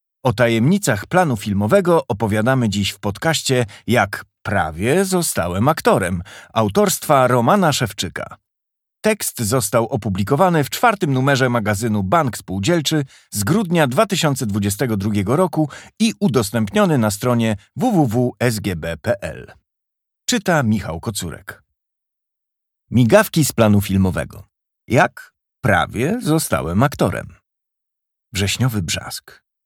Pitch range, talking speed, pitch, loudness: 105-155 Hz, 95 wpm, 120 Hz, -18 LUFS